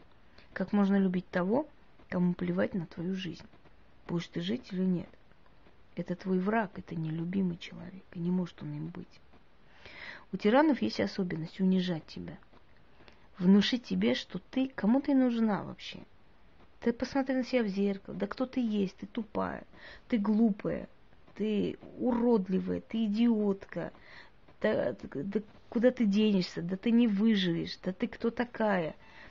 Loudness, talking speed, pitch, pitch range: -31 LUFS, 145 wpm, 200 Hz, 185-230 Hz